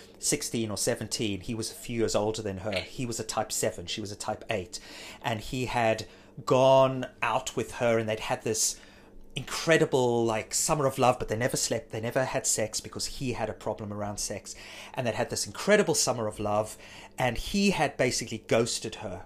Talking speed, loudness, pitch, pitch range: 205 wpm, -28 LUFS, 110 Hz, 105-125 Hz